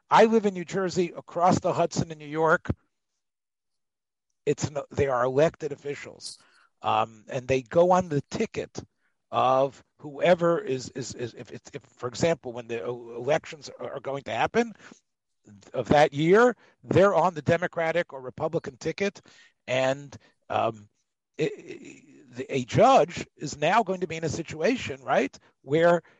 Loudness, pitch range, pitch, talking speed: -26 LUFS, 130-175 Hz, 150 Hz, 150 wpm